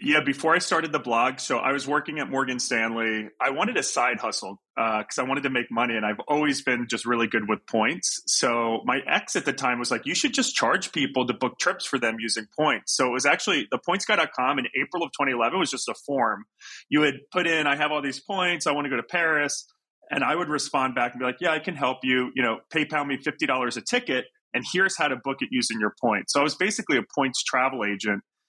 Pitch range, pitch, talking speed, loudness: 120-155 Hz, 135 Hz, 255 wpm, -25 LUFS